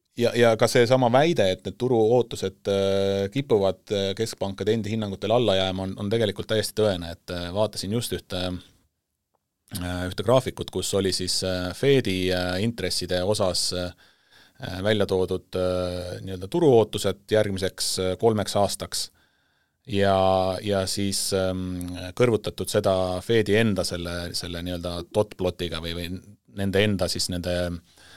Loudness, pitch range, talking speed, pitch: -24 LUFS, 90-105 Hz, 115 wpm, 95 Hz